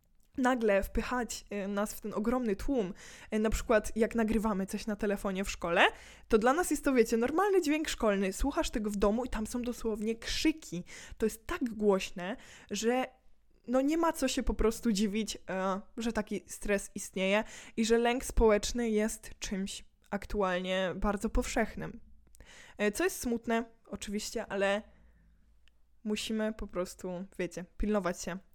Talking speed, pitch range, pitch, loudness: 150 wpm, 200-235 Hz, 215 Hz, -32 LUFS